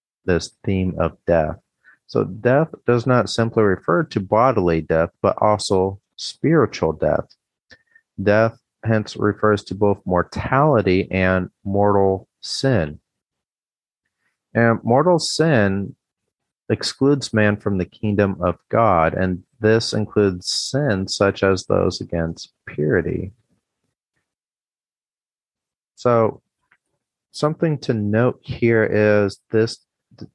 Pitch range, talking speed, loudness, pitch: 95-120 Hz, 105 wpm, -19 LUFS, 105 Hz